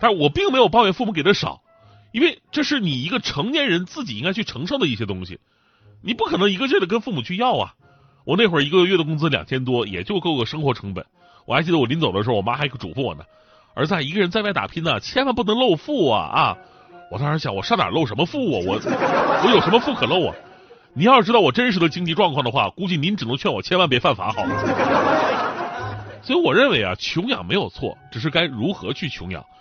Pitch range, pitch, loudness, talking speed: 140-230 Hz, 175 Hz, -20 LUFS, 355 characters per minute